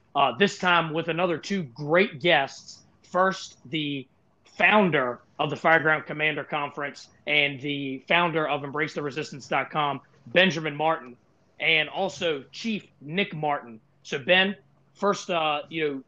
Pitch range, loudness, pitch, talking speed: 145-180 Hz, -25 LUFS, 155 Hz, 130 wpm